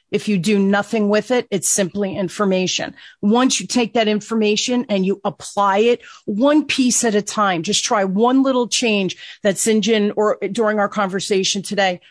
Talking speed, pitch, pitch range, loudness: 180 wpm, 210 Hz, 195-230 Hz, -18 LUFS